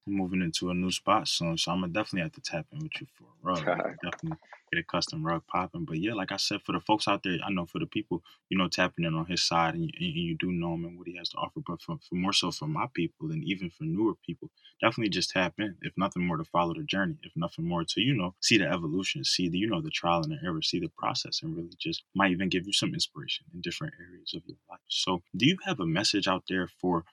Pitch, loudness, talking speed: 100 Hz, -30 LUFS, 290 wpm